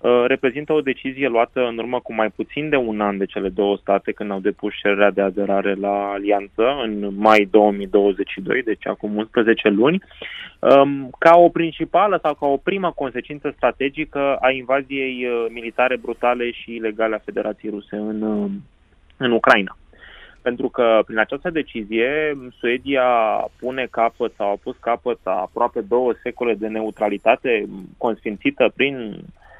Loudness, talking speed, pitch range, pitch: -20 LUFS, 145 wpm, 105-135 Hz, 115 Hz